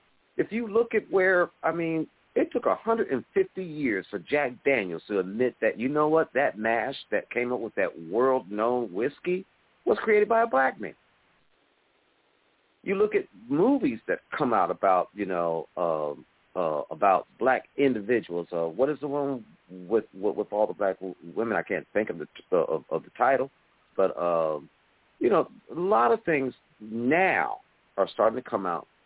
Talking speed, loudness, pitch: 175 wpm, -27 LUFS, 130 Hz